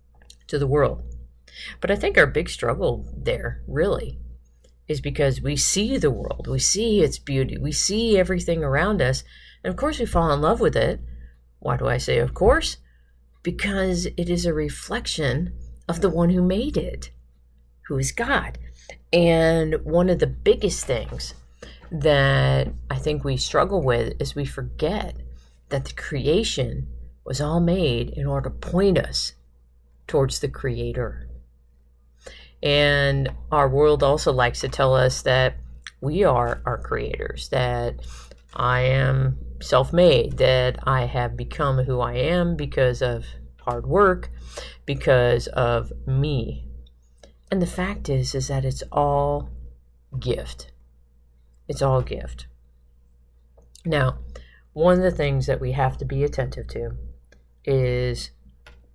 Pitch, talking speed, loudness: 125 Hz, 145 wpm, -22 LUFS